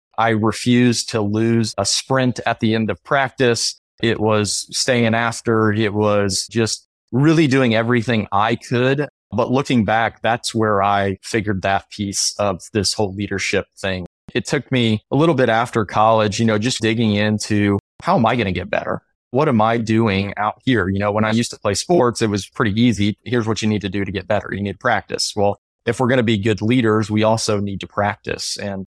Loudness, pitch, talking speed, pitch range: -18 LUFS, 110 Hz, 210 wpm, 105-115 Hz